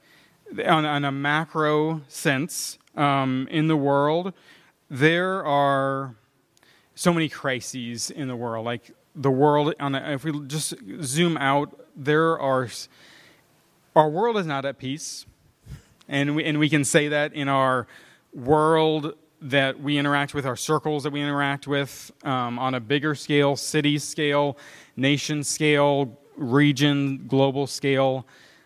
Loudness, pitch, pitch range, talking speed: -23 LUFS, 145 Hz, 135-155 Hz, 140 wpm